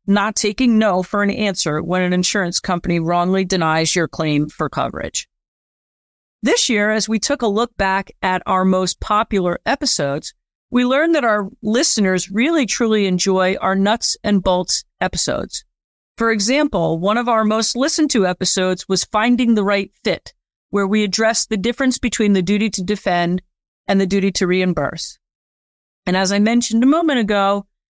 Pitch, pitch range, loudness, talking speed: 200 Hz, 185-225 Hz, -17 LUFS, 170 wpm